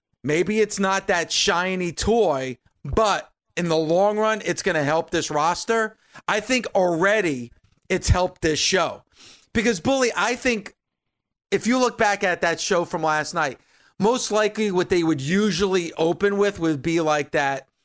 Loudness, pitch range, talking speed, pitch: -22 LUFS, 160-210 Hz, 170 wpm, 180 Hz